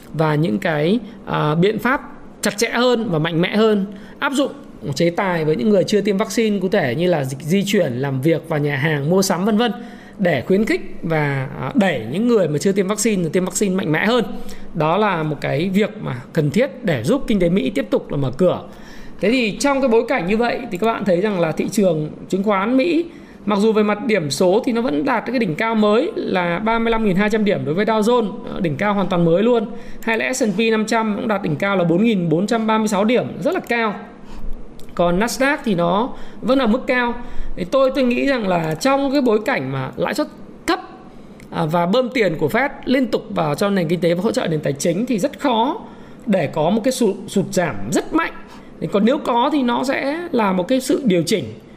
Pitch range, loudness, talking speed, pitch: 180-240 Hz, -18 LUFS, 225 wpm, 220 Hz